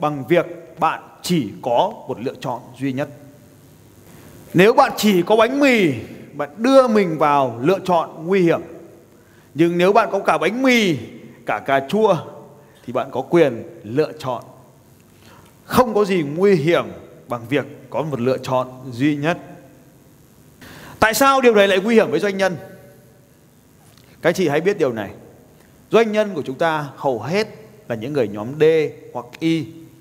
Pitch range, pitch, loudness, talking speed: 140-200 Hz, 160 Hz, -18 LUFS, 165 wpm